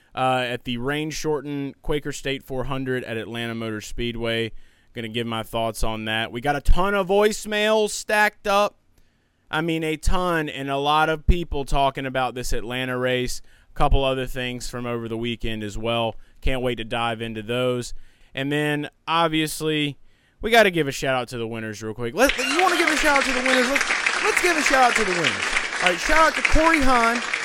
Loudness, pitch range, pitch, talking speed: -22 LUFS, 115-180 Hz, 135 Hz, 210 wpm